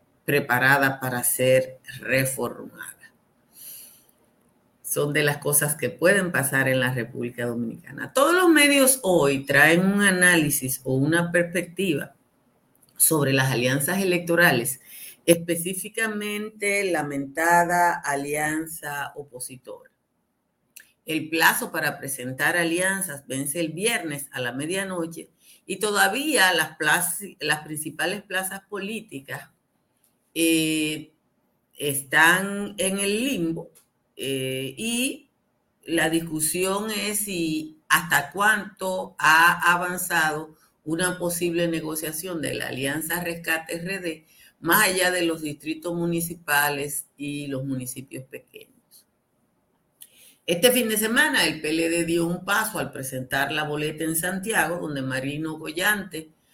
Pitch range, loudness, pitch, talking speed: 145-185 Hz, -23 LUFS, 165 Hz, 110 wpm